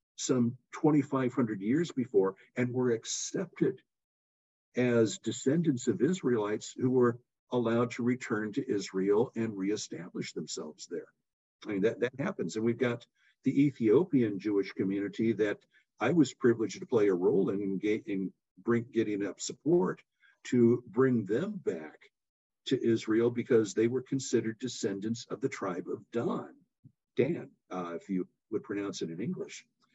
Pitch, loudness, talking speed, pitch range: 115 Hz, -31 LUFS, 150 wpm, 100-125 Hz